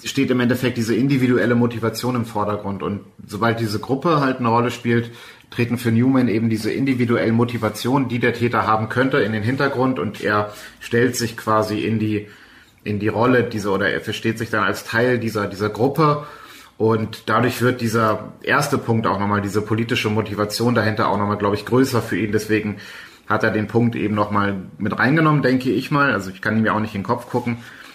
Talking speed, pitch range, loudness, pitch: 200 wpm, 105-120 Hz, -20 LUFS, 115 Hz